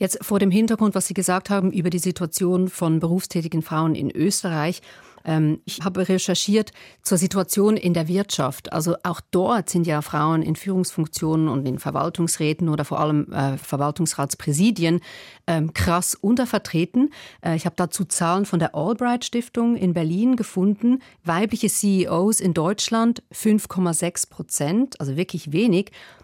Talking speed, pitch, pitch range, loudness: 135 wpm, 180 Hz, 160-200 Hz, -22 LUFS